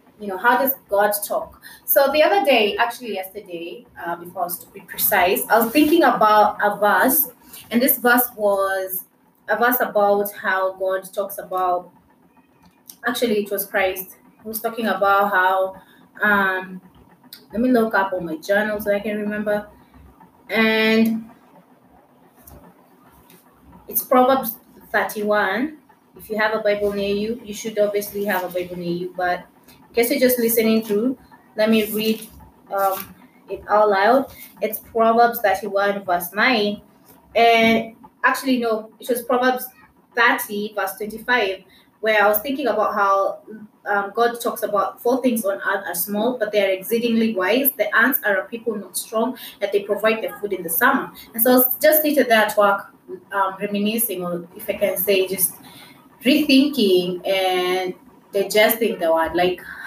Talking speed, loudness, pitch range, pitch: 160 wpm, -19 LUFS, 195-235 Hz, 210 Hz